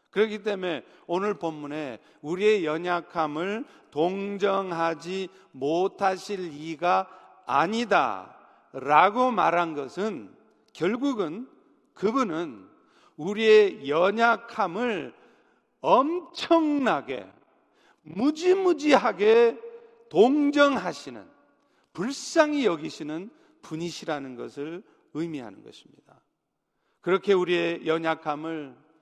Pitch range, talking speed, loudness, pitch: 165-235 Hz, 200 characters per minute, -25 LUFS, 190 Hz